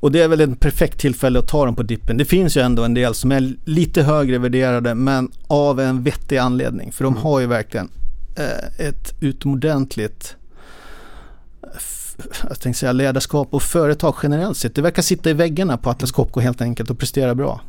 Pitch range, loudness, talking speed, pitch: 125-150 Hz, -18 LUFS, 185 wpm, 135 Hz